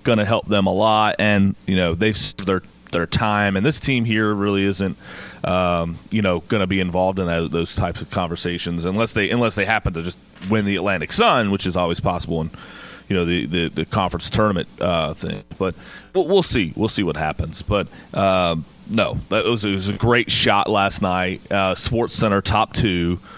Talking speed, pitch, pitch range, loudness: 205 wpm, 100 Hz, 90-110 Hz, -20 LUFS